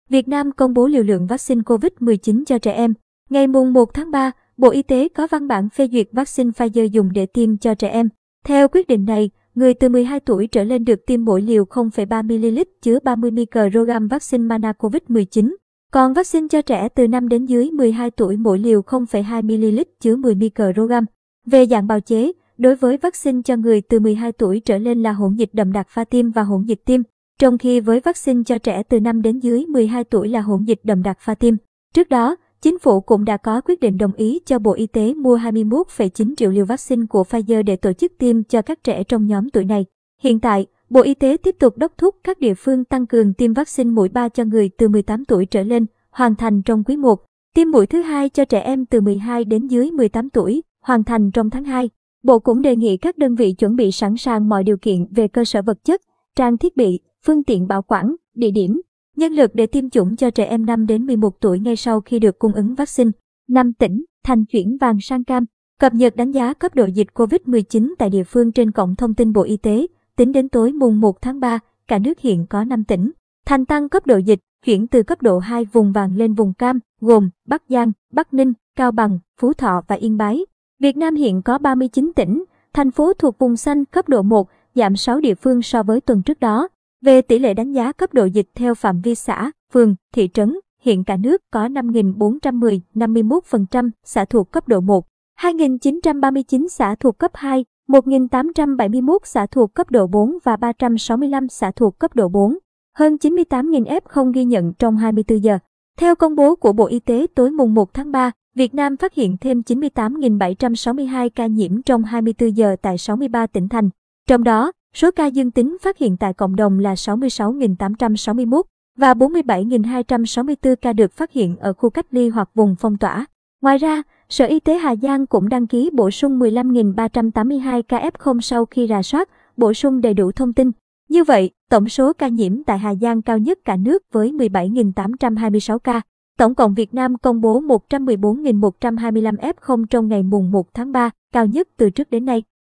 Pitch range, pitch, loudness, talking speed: 220-265 Hz, 235 Hz, -17 LUFS, 210 wpm